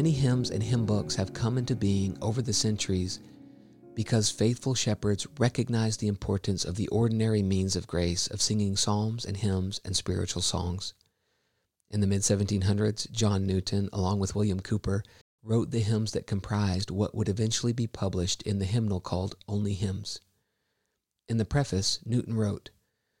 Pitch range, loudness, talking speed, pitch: 95-110 Hz, -29 LUFS, 165 wpm, 105 Hz